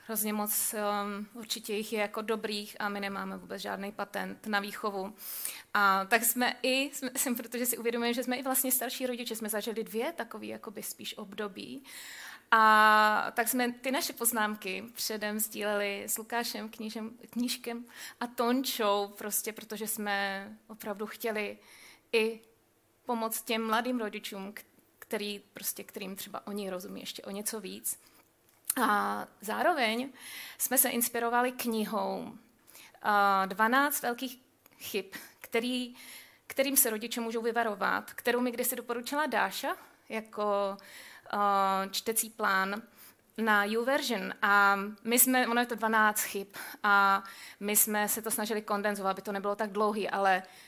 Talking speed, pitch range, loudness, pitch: 140 wpm, 205-240 Hz, -30 LUFS, 220 Hz